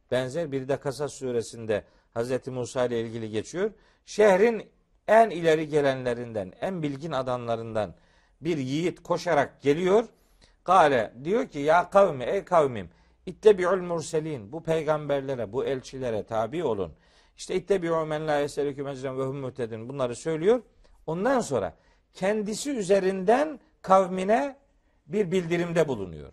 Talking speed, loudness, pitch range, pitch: 115 wpm, -26 LUFS, 130-190 Hz, 155 Hz